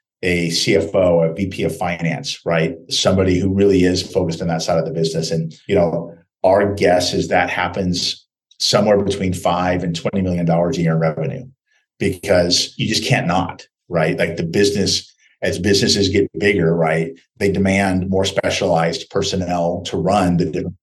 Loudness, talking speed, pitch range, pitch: -18 LUFS, 170 wpm, 85-95 Hz, 90 Hz